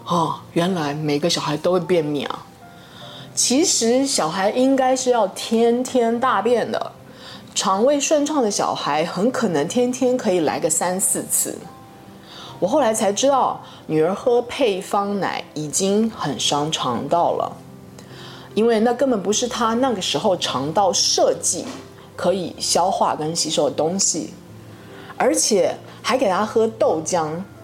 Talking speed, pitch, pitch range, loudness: 210 characters per minute, 215 Hz, 170-250 Hz, -19 LUFS